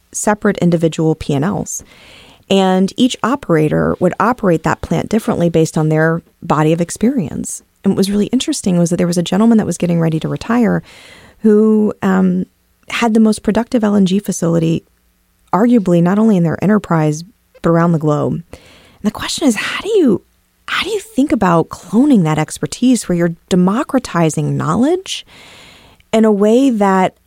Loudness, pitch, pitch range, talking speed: -14 LUFS, 190 Hz, 165-225 Hz, 165 wpm